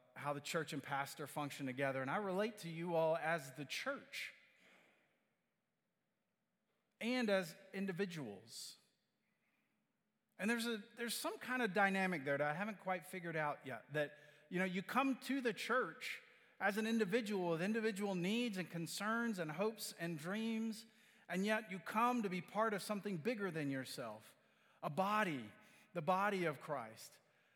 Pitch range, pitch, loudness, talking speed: 160-220 Hz, 195 Hz, -41 LUFS, 160 wpm